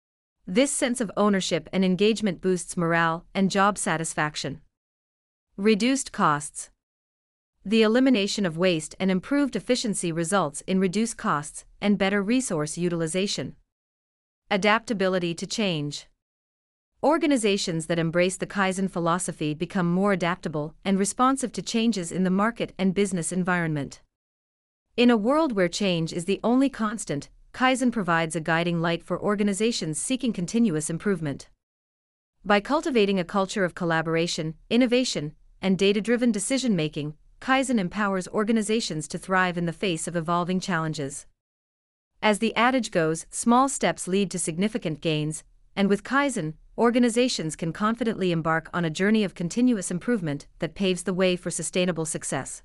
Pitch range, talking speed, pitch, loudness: 160-215 Hz, 140 wpm, 185 Hz, -25 LUFS